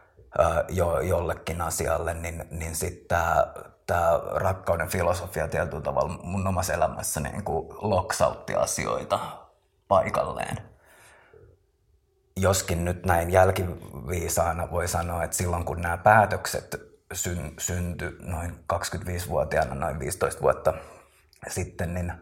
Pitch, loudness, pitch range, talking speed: 85 Hz, -27 LUFS, 85-90 Hz, 105 wpm